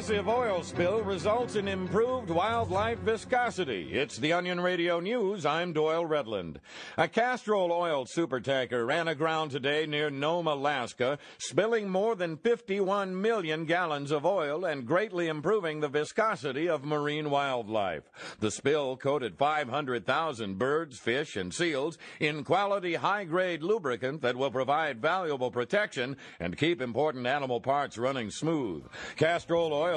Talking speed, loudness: 130 wpm, -30 LUFS